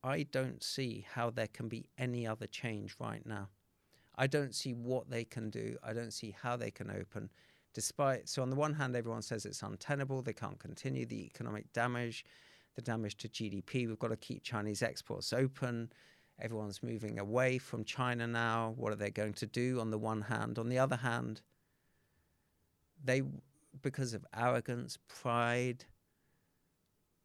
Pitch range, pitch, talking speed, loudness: 110-125 Hz, 115 Hz, 170 wpm, -39 LUFS